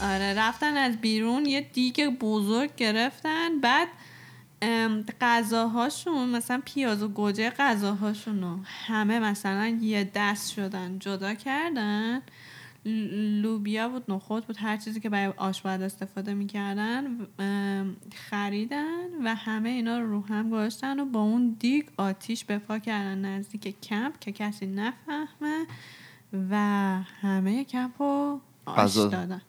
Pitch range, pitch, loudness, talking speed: 200-245 Hz, 220 Hz, -28 LUFS, 120 wpm